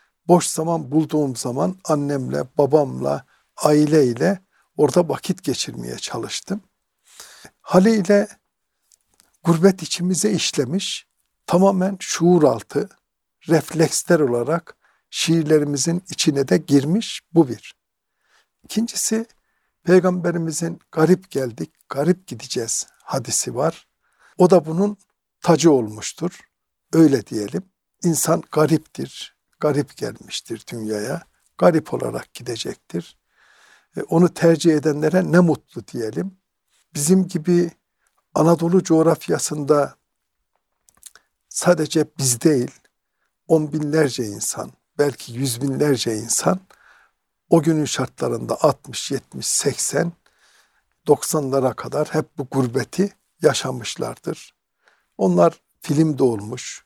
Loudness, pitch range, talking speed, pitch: -20 LUFS, 140-180 Hz, 90 wpm, 160 Hz